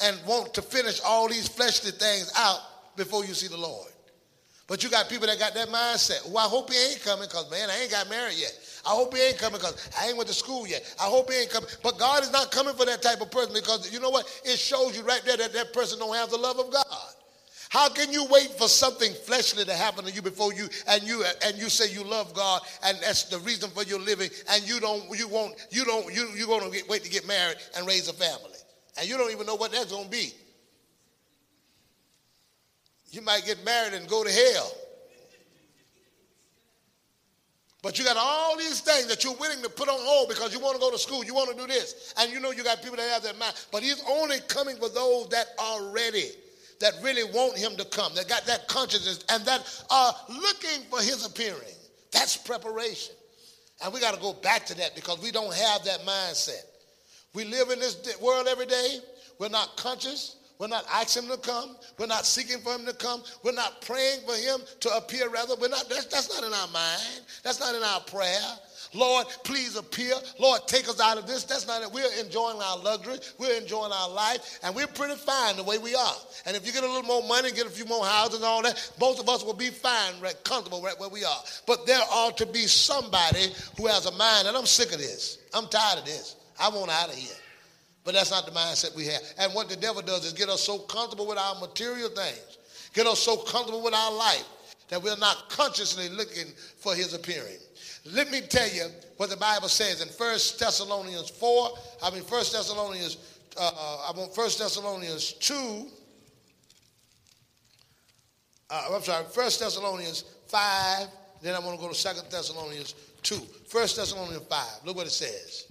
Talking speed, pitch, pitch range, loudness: 220 wpm, 230 Hz, 200-255 Hz, -27 LUFS